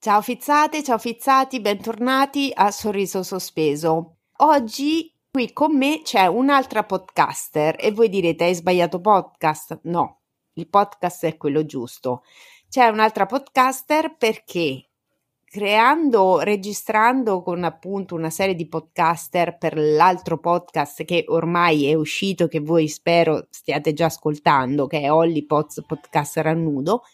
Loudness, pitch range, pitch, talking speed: -20 LUFS, 160-225 Hz, 180 Hz, 130 wpm